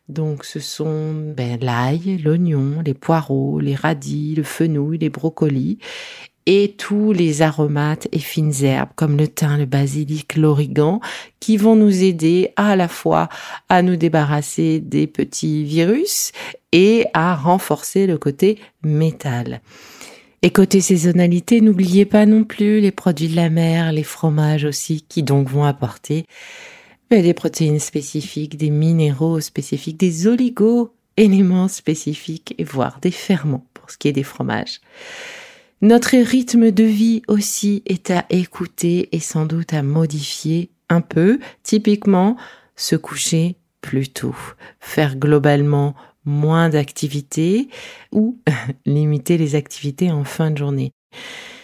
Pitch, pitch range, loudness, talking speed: 165 Hz, 150-200 Hz, -17 LUFS, 140 wpm